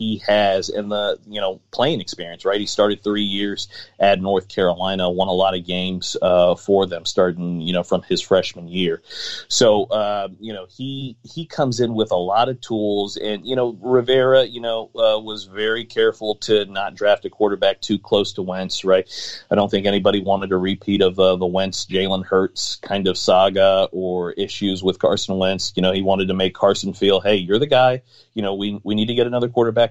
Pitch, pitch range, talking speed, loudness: 100 Hz, 95-110 Hz, 215 wpm, -19 LUFS